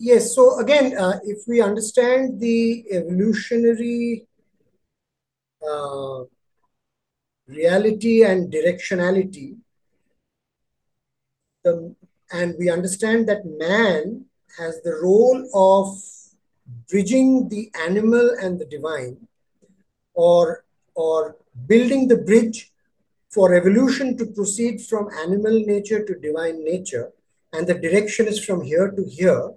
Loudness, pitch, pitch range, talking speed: -19 LUFS, 205 Hz, 175-230 Hz, 105 wpm